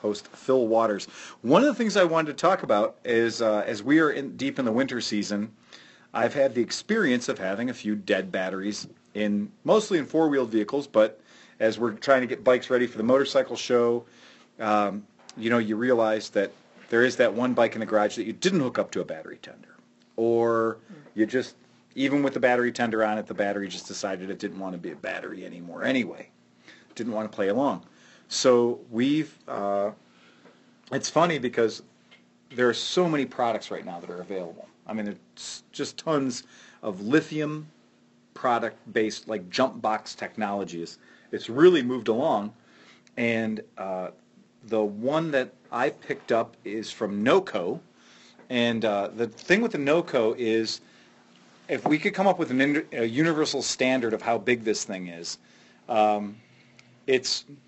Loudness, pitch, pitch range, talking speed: -26 LUFS, 115 Hz, 105-130 Hz, 180 wpm